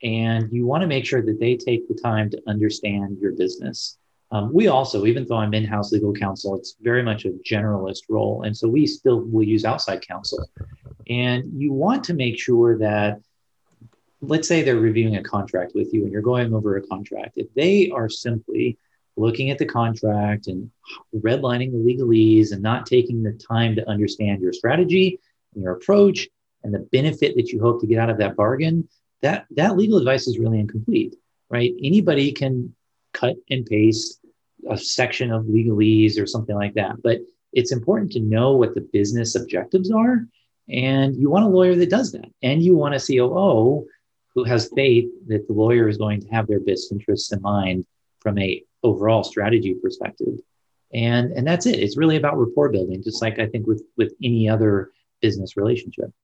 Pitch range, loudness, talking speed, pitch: 110-140 Hz, -20 LUFS, 190 wpm, 115 Hz